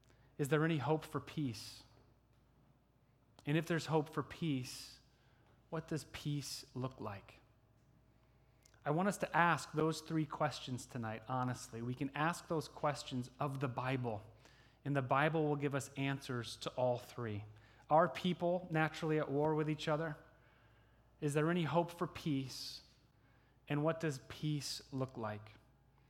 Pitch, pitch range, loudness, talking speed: 135 Hz, 125-155 Hz, -39 LUFS, 150 wpm